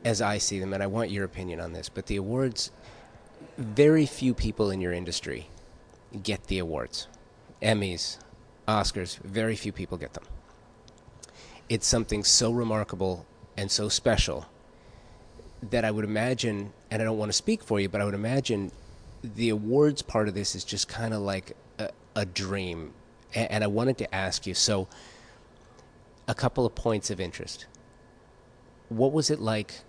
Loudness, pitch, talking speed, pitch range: -28 LUFS, 110 Hz, 165 wpm, 100-115 Hz